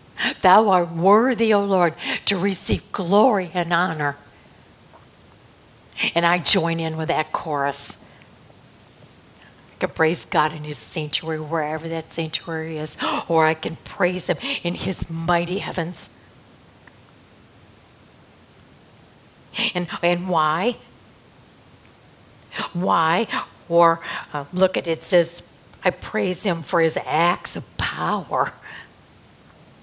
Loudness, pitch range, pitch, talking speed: -21 LUFS, 160-185 Hz, 170 Hz, 115 wpm